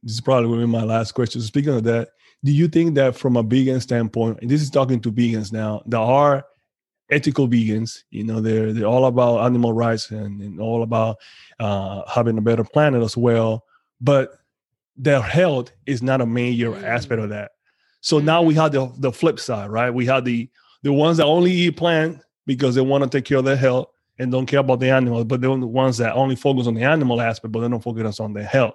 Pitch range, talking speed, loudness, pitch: 115-140 Hz, 230 wpm, -19 LUFS, 125 Hz